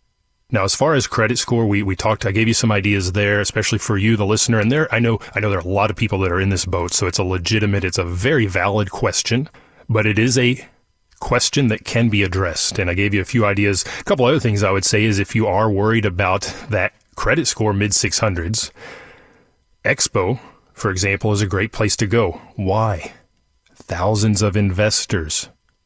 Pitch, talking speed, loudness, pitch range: 105 Hz, 215 wpm, -18 LUFS, 100-110 Hz